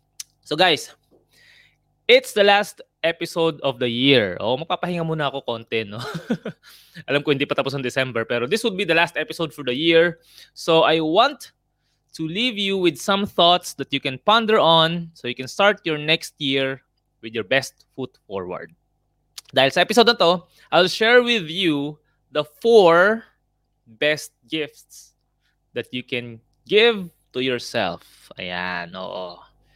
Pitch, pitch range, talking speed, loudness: 155 Hz, 135-180 Hz, 160 wpm, -20 LUFS